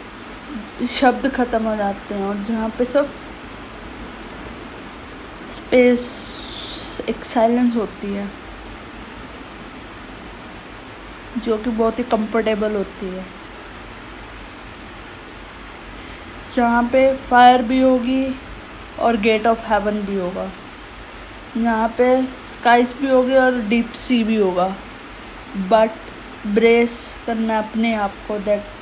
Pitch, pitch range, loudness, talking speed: 230 Hz, 215-245 Hz, -18 LUFS, 100 wpm